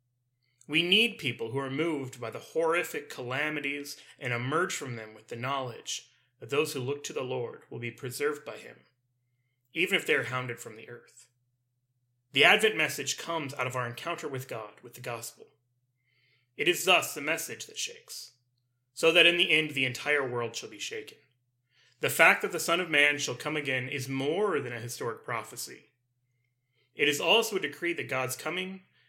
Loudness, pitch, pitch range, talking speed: -28 LUFS, 130 Hz, 125-150 Hz, 190 wpm